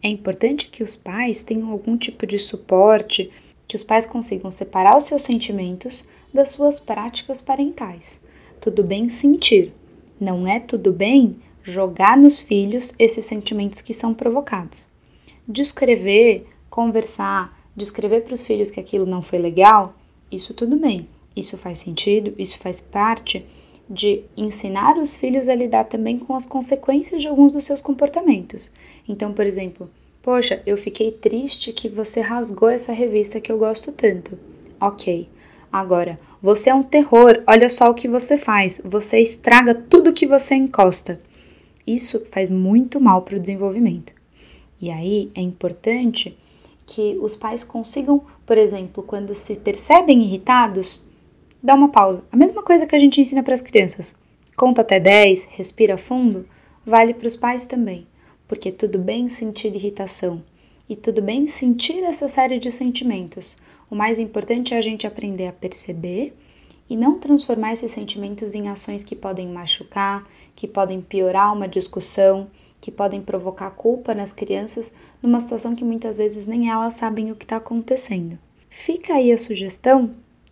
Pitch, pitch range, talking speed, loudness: 220 Hz, 200-245 Hz, 155 wpm, -17 LUFS